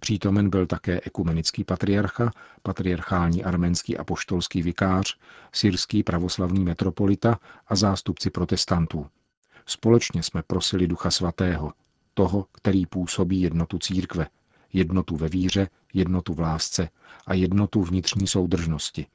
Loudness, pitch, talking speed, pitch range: -25 LUFS, 95 Hz, 115 wpm, 90-100 Hz